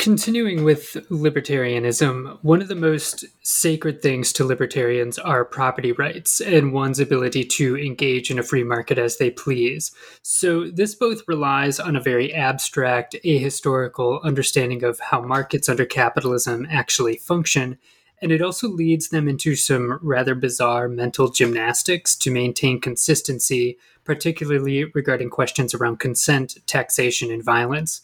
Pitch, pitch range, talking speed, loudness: 135 Hz, 125-155 Hz, 140 wpm, -20 LUFS